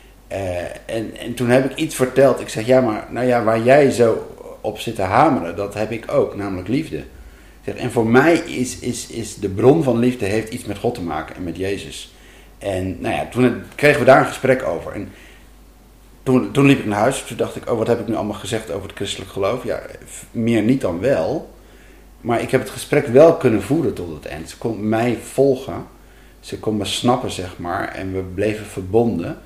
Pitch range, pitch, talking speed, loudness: 105-130 Hz, 115 Hz, 220 wpm, -19 LUFS